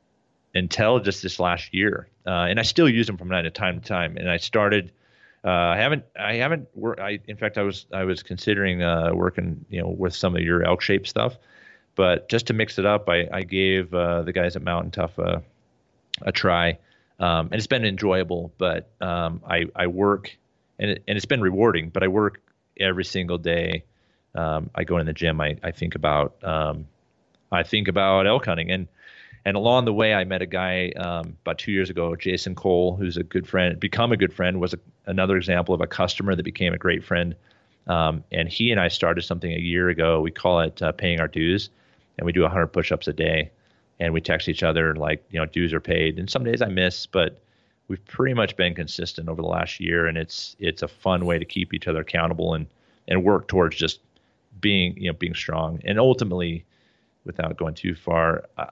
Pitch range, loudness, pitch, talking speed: 85-100 Hz, -23 LUFS, 90 Hz, 220 wpm